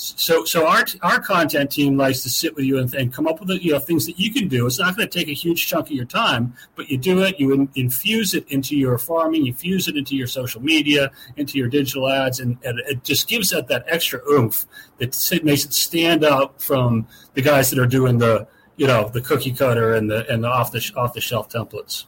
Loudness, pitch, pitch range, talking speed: -19 LUFS, 135 Hz, 125-160 Hz, 245 wpm